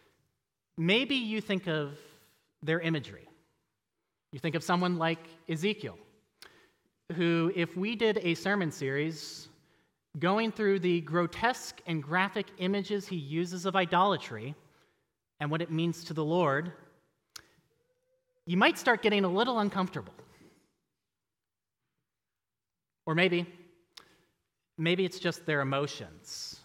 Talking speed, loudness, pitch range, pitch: 115 wpm, -30 LUFS, 155-195 Hz, 175 Hz